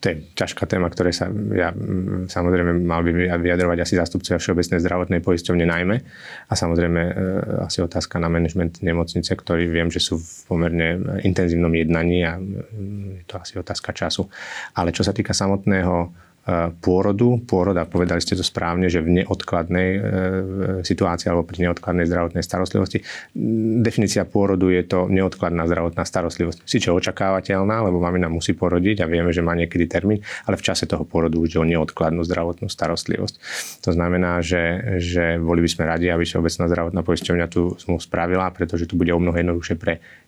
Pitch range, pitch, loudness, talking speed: 85-95 Hz, 90 Hz, -21 LUFS, 170 wpm